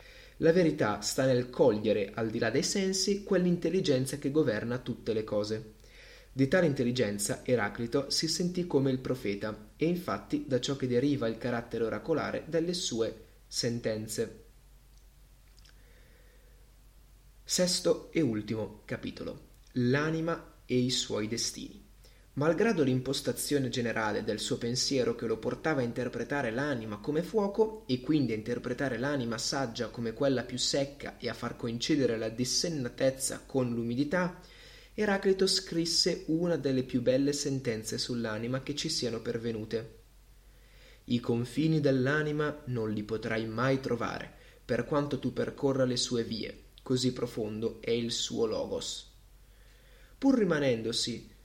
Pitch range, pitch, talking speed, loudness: 115-150 Hz, 130 Hz, 130 wpm, -31 LUFS